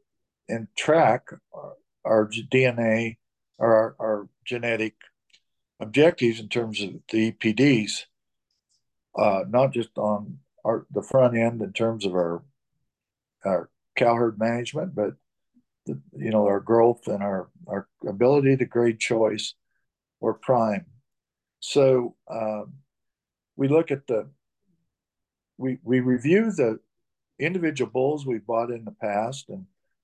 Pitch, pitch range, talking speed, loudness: 115 Hz, 110-135 Hz, 130 wpm, -24 LUFS